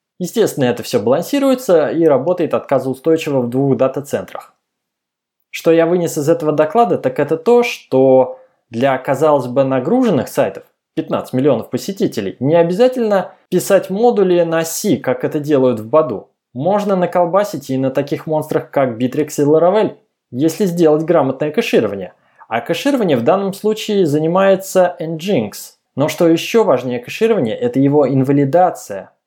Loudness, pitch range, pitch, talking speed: -15 LUFS, 140-190 Hz, 160 Hz, 140 wpm